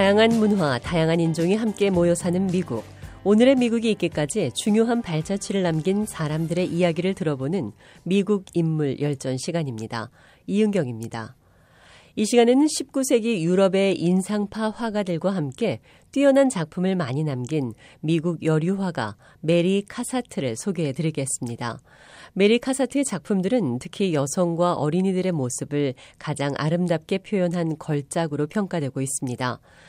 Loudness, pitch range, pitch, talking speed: -23 LUFS, 145-200 Hz, 175 Hz, 325 characters per minute